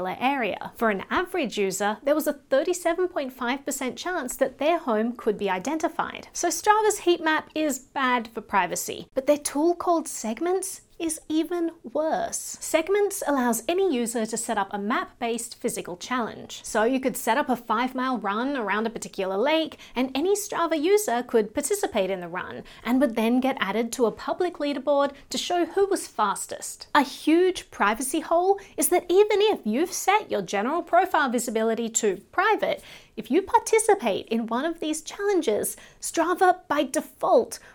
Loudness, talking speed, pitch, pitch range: -25 LUFS, 170 wpm, 290 Hz, 230-345 Hz